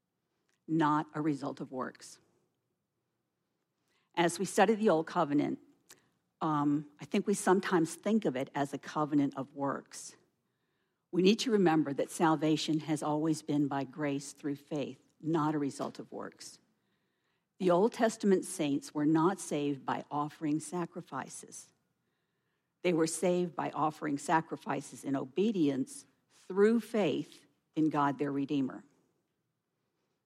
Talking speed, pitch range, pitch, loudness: 130 wpm, 145-180 Hz, 155 Hz, -32 LUFS